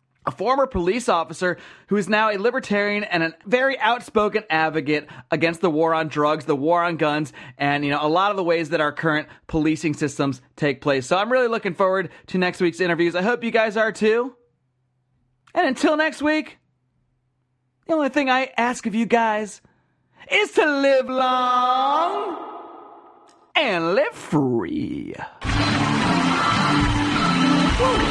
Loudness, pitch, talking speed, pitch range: -21 LUFS, 195 Hz, 155 wpm, 155-255 Hz